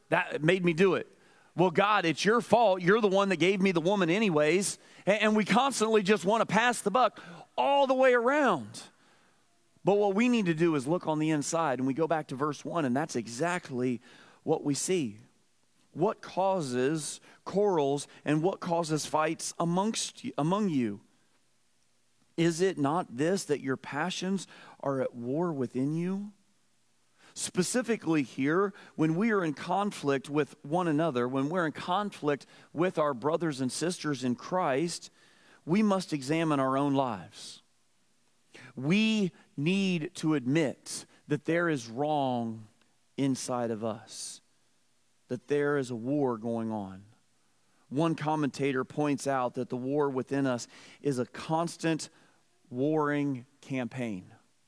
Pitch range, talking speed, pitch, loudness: 135-185 Hz, 150 wpm, 155 Hz, -29 LUFS